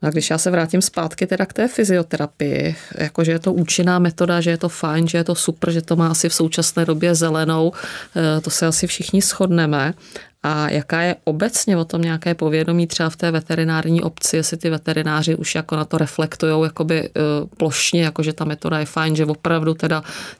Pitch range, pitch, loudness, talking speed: 155-170 Hz, 165 Hz, -19 LUFS, 195 wpm